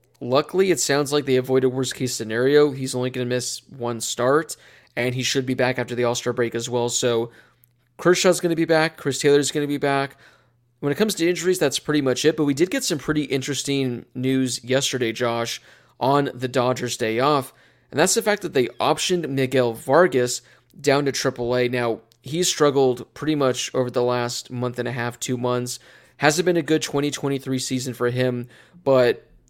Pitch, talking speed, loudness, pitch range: 130 Hz, 200 wpm, -22 LUFS, 125-150 Hz